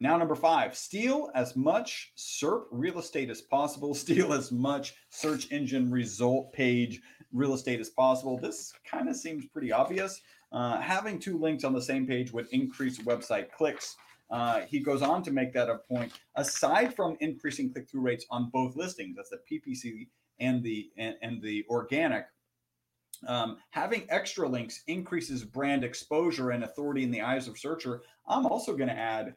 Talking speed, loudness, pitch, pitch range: 175 wpm, -31 LUFS, 135 Hz, 120-165 Hz